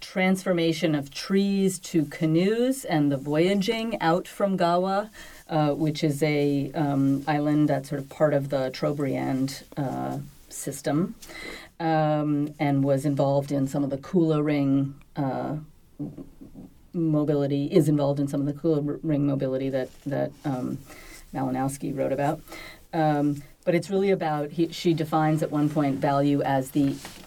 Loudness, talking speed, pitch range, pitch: -25 LUFS, 150 wpm, 140-165 Hz, 150 Hz